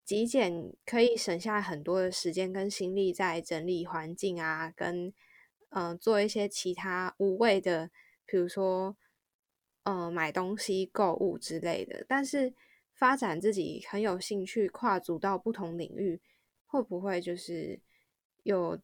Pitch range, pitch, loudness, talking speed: 175-210 Hz, 190 Hz, -32 LUFS, 215 characters per minute